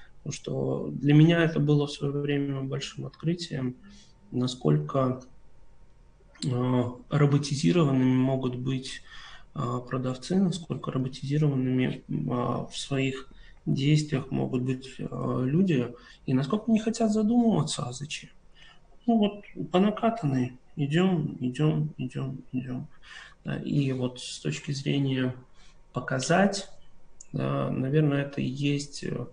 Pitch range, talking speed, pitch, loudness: 130-155 Hz, 115 wpm, 140 Hz, -28 LUFS